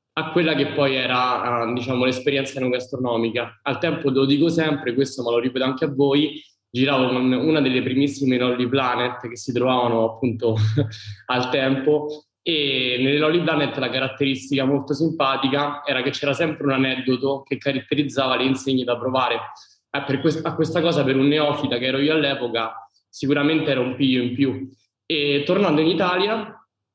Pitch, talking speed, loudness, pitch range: 135 Hz, 175 wpm, -21 LUFS, 125-145 Hz